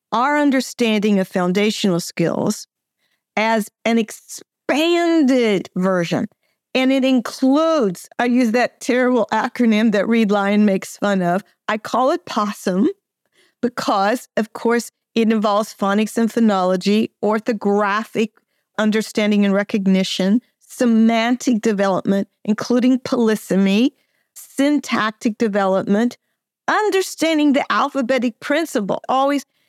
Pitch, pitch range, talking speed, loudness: 225 Hz, 205-255 Hz, 100 wpm, -18 LUFS